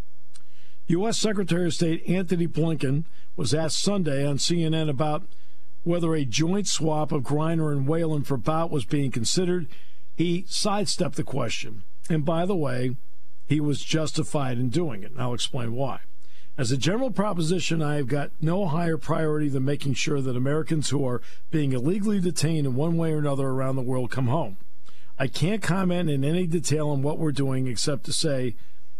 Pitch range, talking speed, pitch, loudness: 135-165 Hz, 180 wpm, 155 Hz, -26 LUFS